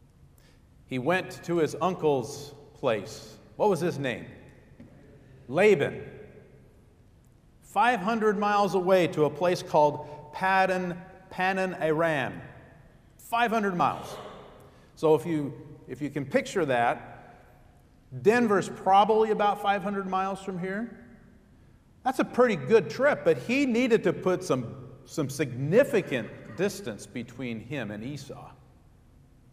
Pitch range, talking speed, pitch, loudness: 145-200 Hz, 110 wpm, 170 Hz, -27 LUFS